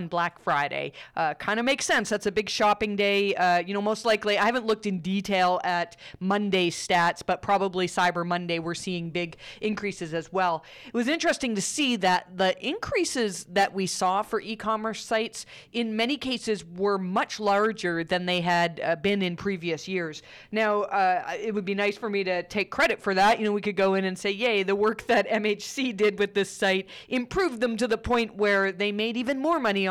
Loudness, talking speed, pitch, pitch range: -26 LUFS, 210 wpm, 200 Hz, 185-220 Hz